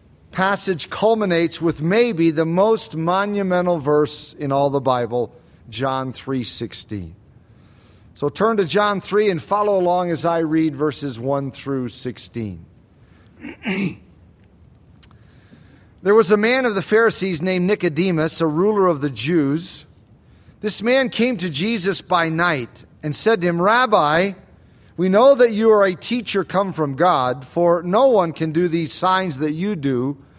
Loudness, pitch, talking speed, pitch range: -19 LUFS, 165 Hz, 150 wpm, 130-195 Hz